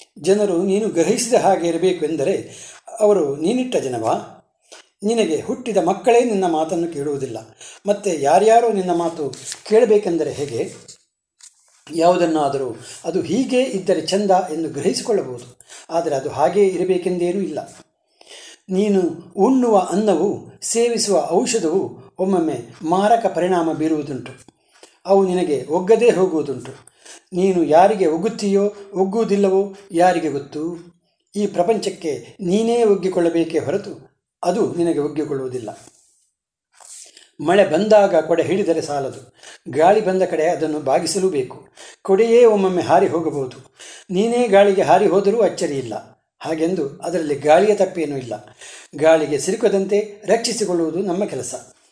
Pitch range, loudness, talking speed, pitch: 160-205 Hz, -18 LUFS, 105 wpm, 185 Hz